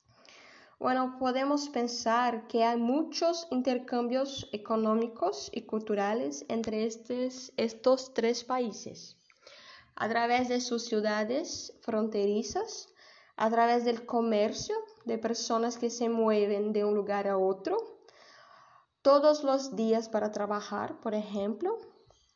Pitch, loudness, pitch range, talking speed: 235 Hz, -30 LUFS, 220-270 Hz, 115 wpm